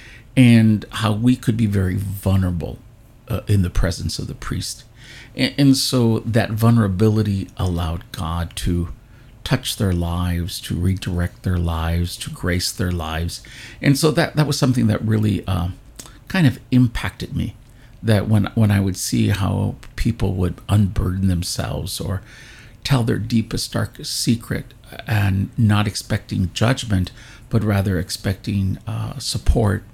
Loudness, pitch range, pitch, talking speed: -20 LUFS, 95-120 Hz, 110 Hz, 145 wpm